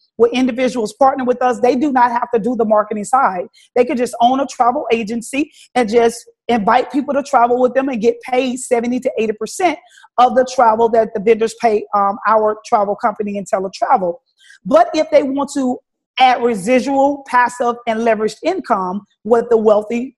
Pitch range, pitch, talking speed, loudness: 225-260 Hz, 240 Hz, 185 wpm, -15 LUFS